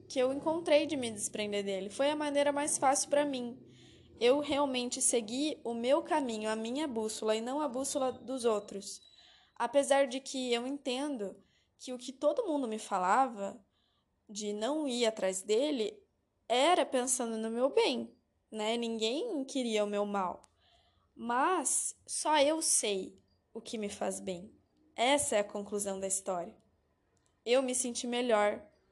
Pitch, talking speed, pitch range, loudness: 245 Hz, 160 wpm, 215-280 Hz, -32 LUFS